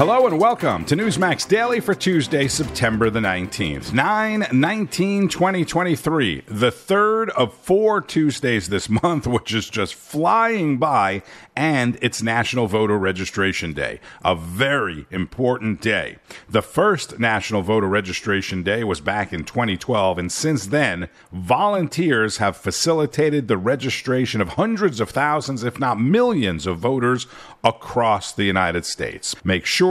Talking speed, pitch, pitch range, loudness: 135 wpm, 125 Hz, 100-165 Hz, -20 LUFS